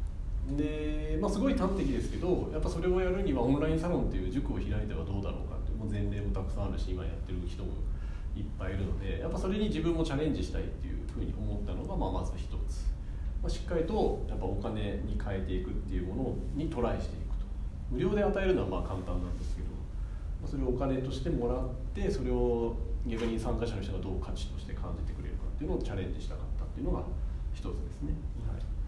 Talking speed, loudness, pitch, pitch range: 465 characters per minute, -34 LUFS, 95 Hz, 75-115 Hz